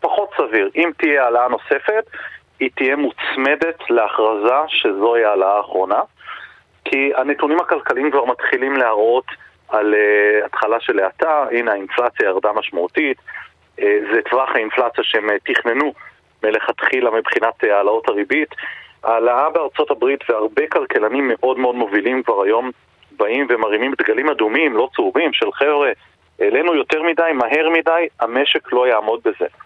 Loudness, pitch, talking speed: -17 LUFS, 165 Hz, 125 wpm